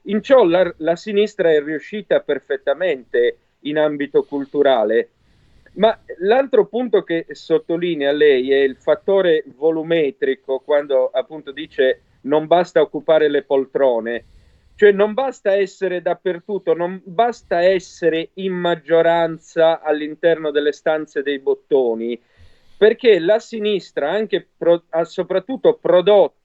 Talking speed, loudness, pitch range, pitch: 115 wpm, -18 LUFS, 150-210 Hz, 170 Hz